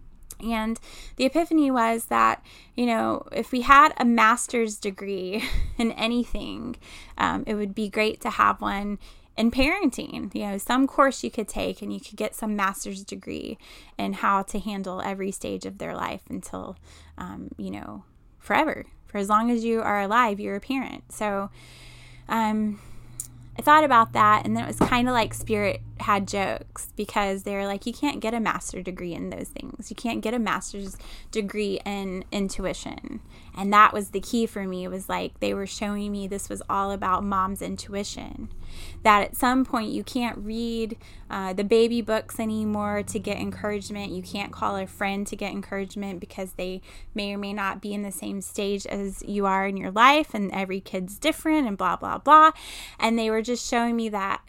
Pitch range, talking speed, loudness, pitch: 195-230 Hz, 190 wpm, -25 LUFS, 205 Hz